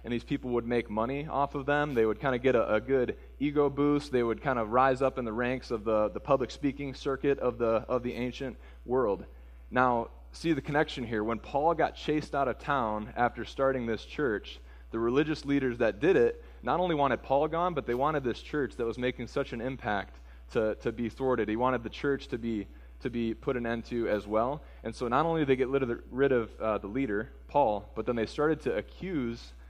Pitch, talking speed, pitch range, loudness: 125 Hz, 240 wpm, 115-140 Hz, -30 LUFS